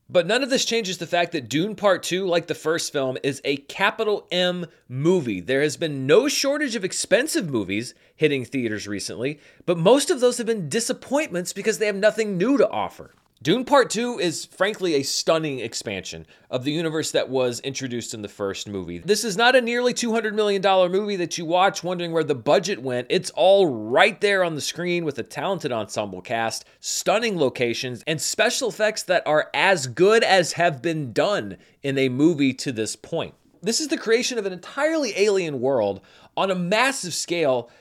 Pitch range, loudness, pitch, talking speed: 135-210 Hz, -22 LUFS, 175 Hz, 195 wpm